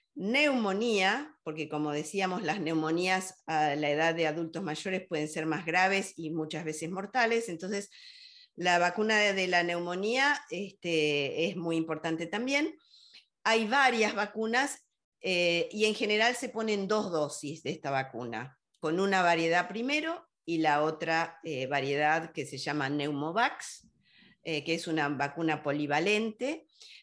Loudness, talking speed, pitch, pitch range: -30 LUFS, 140 wpm, 175 Hz, 155-220 Hz